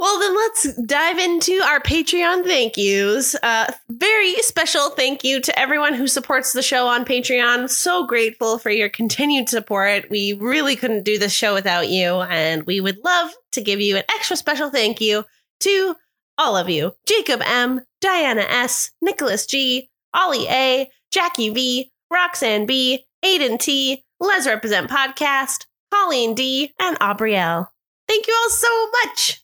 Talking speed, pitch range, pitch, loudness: 160 wpm, 225-355 Hz, 265 Hz, -18 LUFS